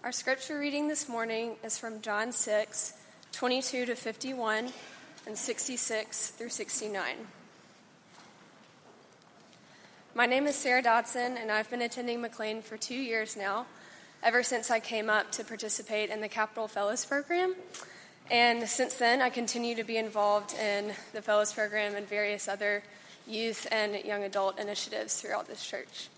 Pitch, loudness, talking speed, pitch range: 225 Hz, -30 LUFS, 150 wpm, 215-245 Hz